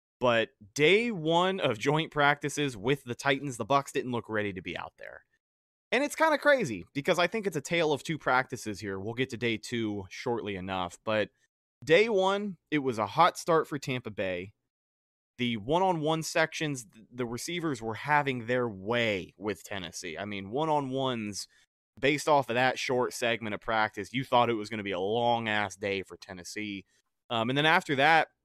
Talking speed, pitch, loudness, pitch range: 200 wpm, 125 Hz, -29 LUFS, 105-150 Hz